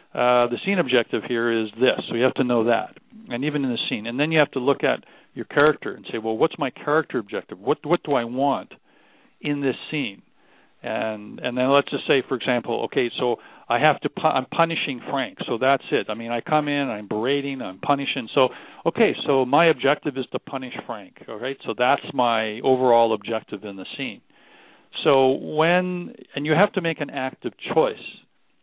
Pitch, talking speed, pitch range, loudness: 135 Hz, 210 wpm, 120-150 Hz, -23 LUFS